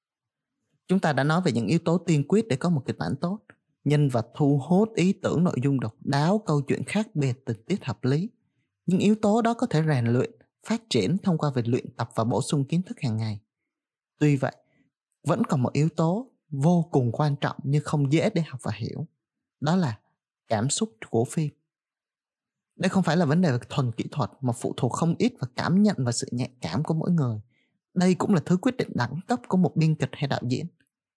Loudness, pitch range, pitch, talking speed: -26 LUFS, 130-180 Hz, 150 Hz, 230 wpm